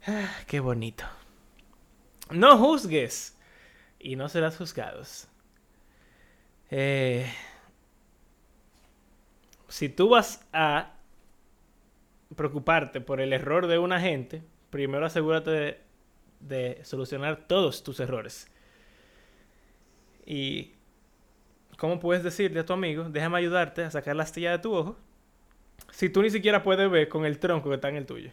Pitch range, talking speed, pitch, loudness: 140-180 Hz, 125 wpm, 160 Hz, -26 LUFS